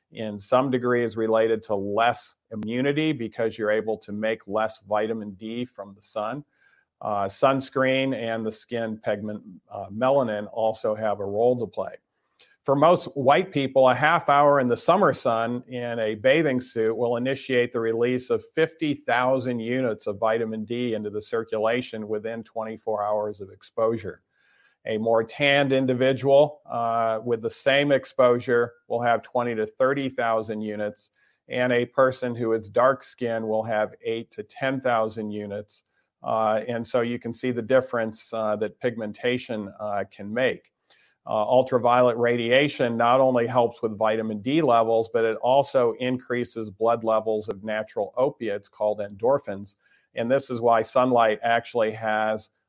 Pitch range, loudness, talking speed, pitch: 110-125 Hz, -24 LUFS, 155 wpm, 115 Hz